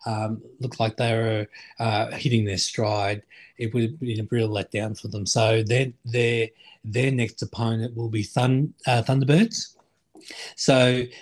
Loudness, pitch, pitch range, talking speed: -24 LUFS, 115 Hz, 110-125 Hz, 160 wpm